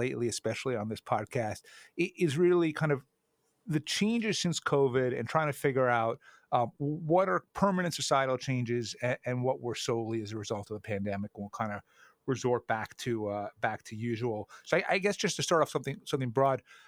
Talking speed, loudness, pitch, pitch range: 200 wpm, -31 LUFS, 130 Hz, 115-155 Hz